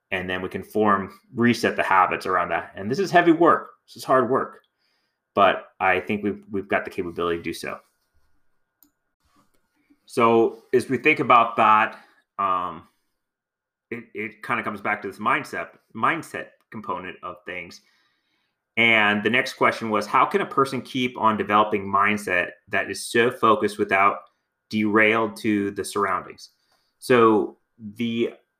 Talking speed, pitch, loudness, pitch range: 155 wpm, 110 Hz, -22 LUFS, 105-130 Hz